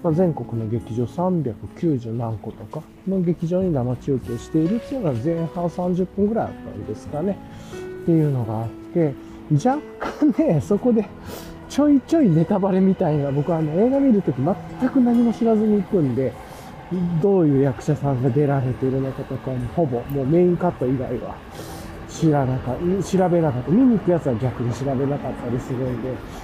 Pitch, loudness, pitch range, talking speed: 155 Hz, -21 LUFS, 125-185 Hz, 350 characters per minute